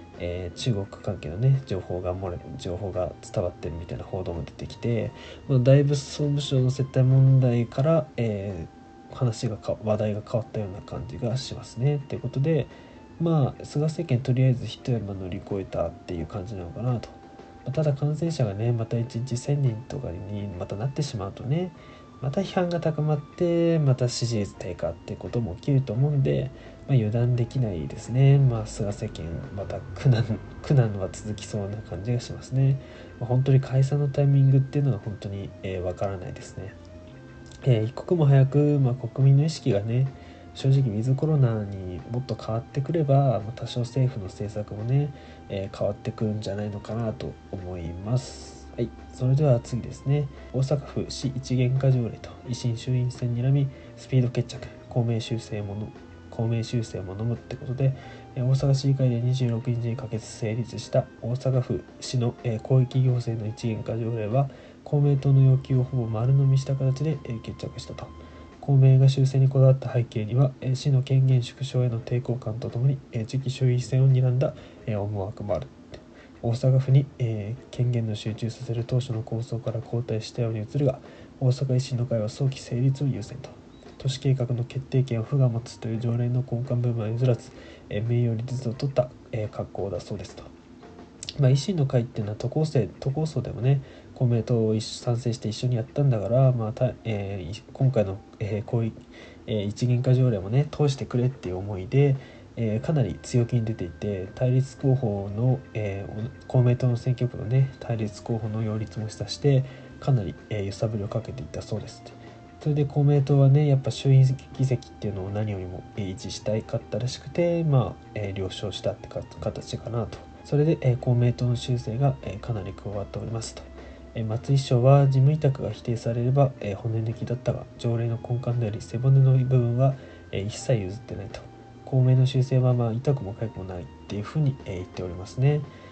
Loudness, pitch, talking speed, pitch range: -26 LUFS, 120 Hz, 350 characters per minute, 105-130 Hz